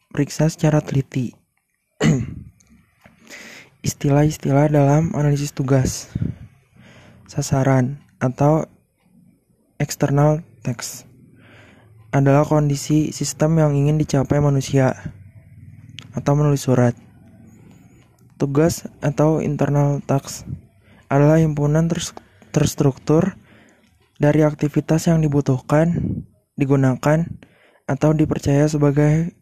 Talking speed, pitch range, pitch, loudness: 75 wpm, 130-150 Hz, 145 Hz, -19 LUFS